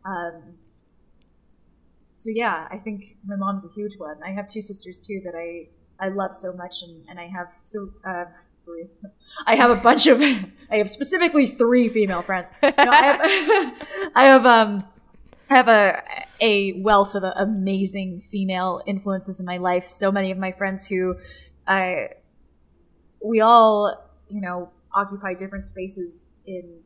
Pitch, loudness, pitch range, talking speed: 195 Hz, -19 LUFS, 180-215 Hz, 165 wpm